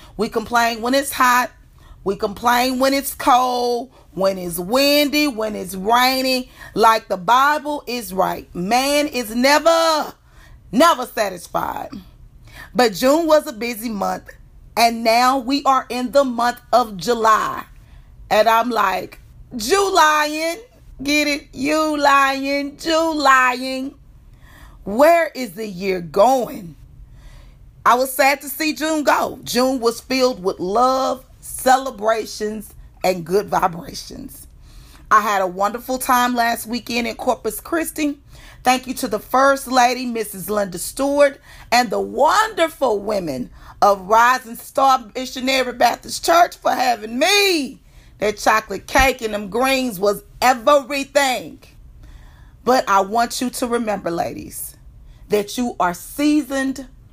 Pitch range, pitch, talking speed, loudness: 220-280 Hz, 250 Hz, 130 wpm, -18 LUFS